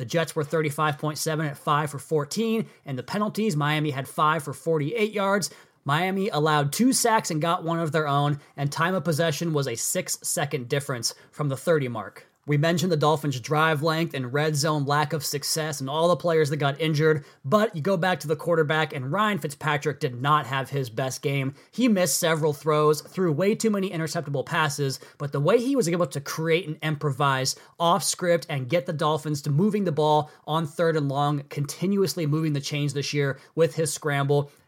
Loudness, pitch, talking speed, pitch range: -25 LUFS, 155 Hz, 205 wpm, 145-170 Hz